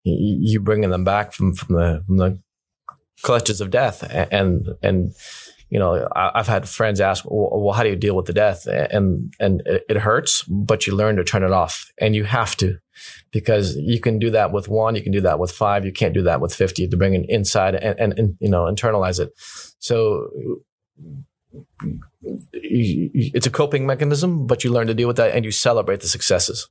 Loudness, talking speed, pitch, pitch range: -19 LUFS, 210 wpm, 105 Hz, 95-115 Hz